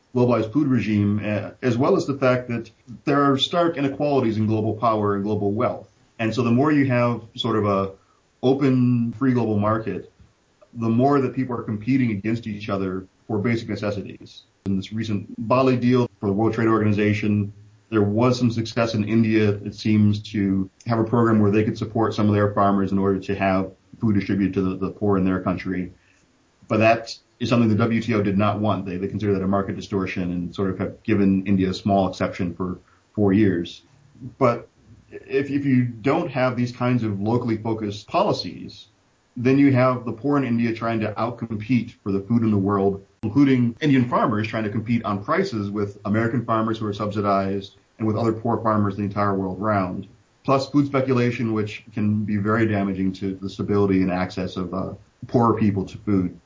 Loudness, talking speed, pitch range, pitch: -22 LUFS, 195 wpm, 100-120 Hz, 110 Hz